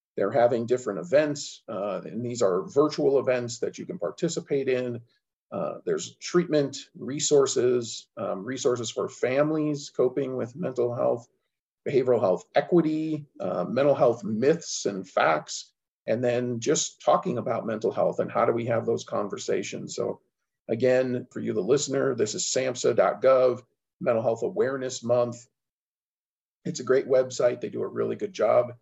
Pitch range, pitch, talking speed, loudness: 120-145 Hz, 130 Hz, 150 wpm, -26 LUFS